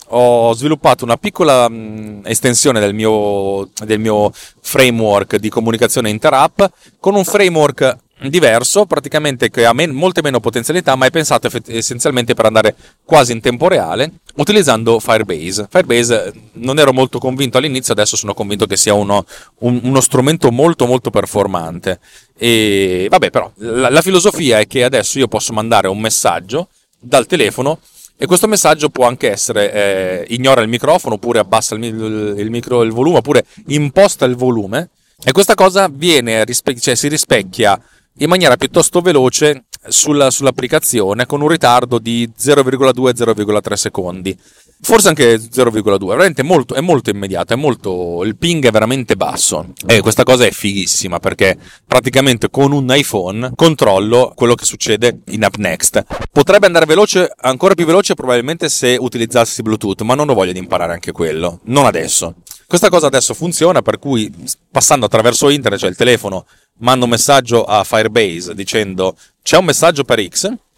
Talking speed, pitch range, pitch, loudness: 160 wpm, 110-145 Hz, 125 Hz, -12 LUFS